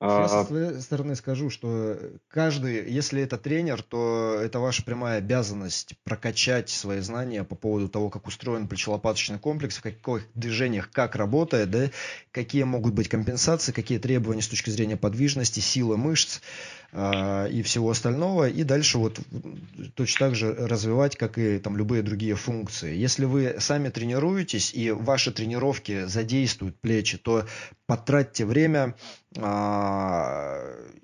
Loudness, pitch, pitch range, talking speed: -26 LUFS, 115 Hz, 110-135 Hz, 140 wpm